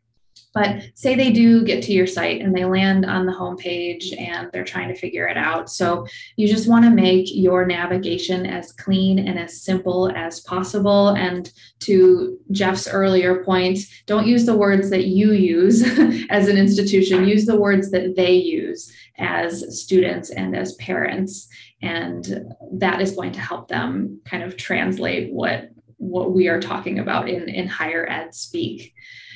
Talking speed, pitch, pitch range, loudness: 170 wpm, 190 Hz, 180-210 Hz, -19 LUFS